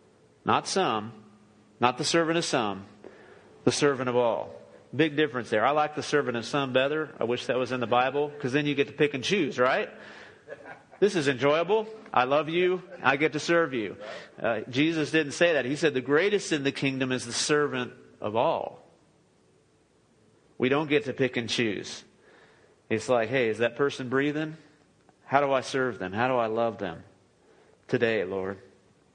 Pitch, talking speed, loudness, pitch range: 135 Hz, 185 wpm, -27 LUFS, 115-150 Hz